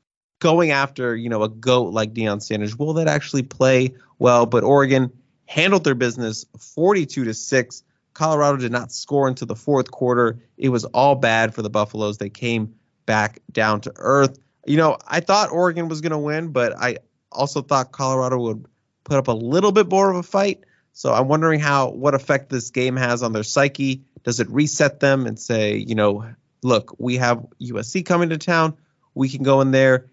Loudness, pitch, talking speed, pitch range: -20 LUFS, 130 Hz, 195 wpm, 120-145 Hz